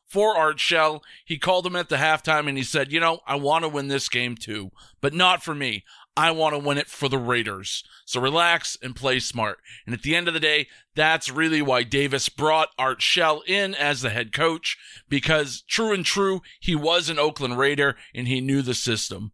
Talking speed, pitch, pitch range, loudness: 220 wpm, 145 Hz, 130-165 Hz, -22 LUFS